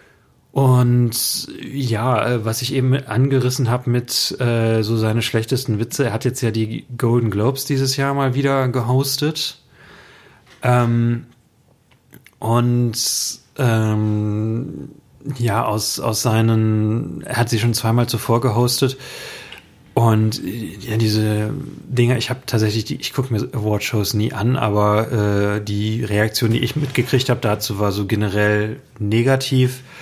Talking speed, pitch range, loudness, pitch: 130 wpm, 110-130 Hz, -19 LUFS, 120 Hz